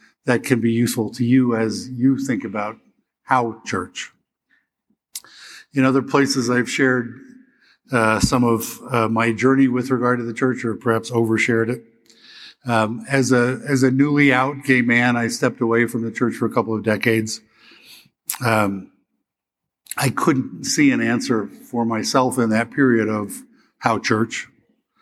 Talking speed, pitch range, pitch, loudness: 160 wpm, 115-130 Hz, 120 Hz, -19 LUFS